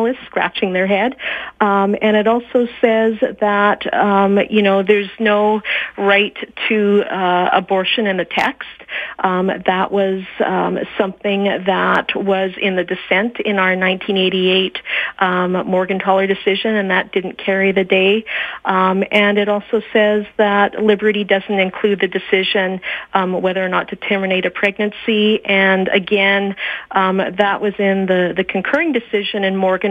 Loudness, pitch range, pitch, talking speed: -16 LUFS, 190-210 Hz, 200 Hz, 150 wpm